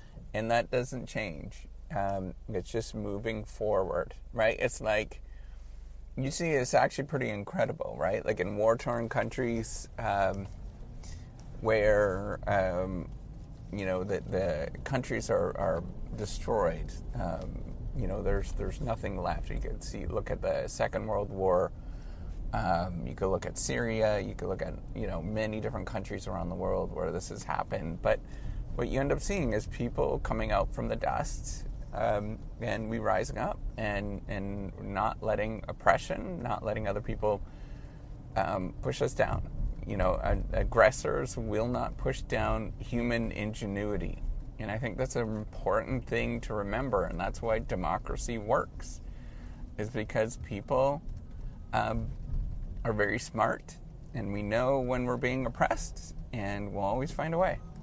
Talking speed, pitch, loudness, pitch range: 150 wpm, 105 Hz, -32 LUFS, 95-115 Hz